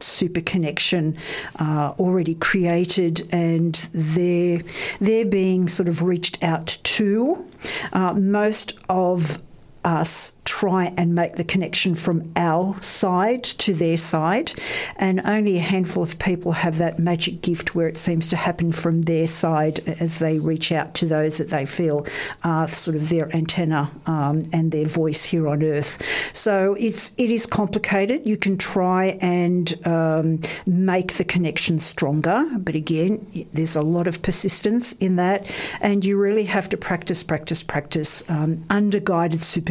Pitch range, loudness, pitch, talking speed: 160-190 Hz, -21 LUFS, 175 Hz, 155 wpm